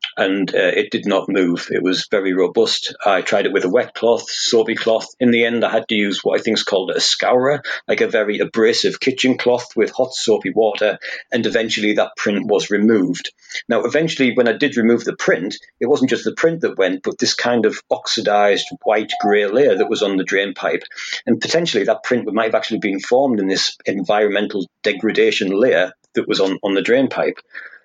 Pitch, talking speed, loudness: 125 Hz, 215 wpm, -17 LUFS